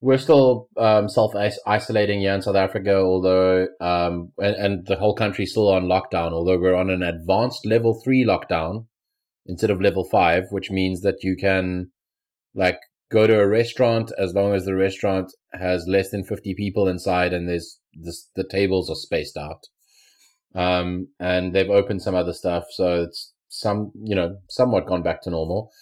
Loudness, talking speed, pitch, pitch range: -21 LUFS, 175 wpm, 95 Hz, 90-105 Hz